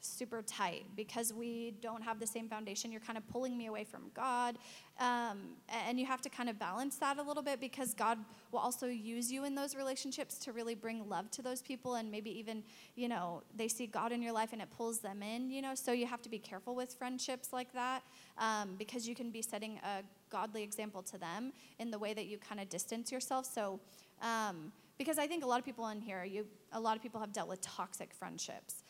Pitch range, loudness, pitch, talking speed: 215-250 Hz, -41 LUFS, 230 Hz, 235 wpm